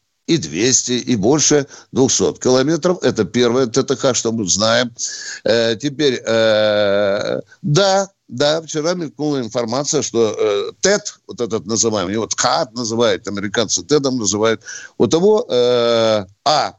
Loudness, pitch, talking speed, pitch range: -16 LUFS, 125 Hz, 130 wpm, 115-150 Hz